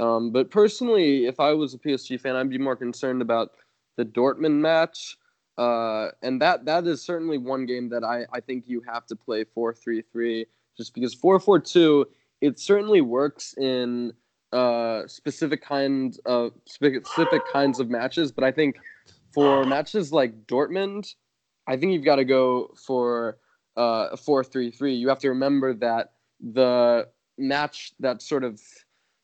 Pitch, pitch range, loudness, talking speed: 130 Hz, 120-145 Hz, -24 LUFS, 155 wpm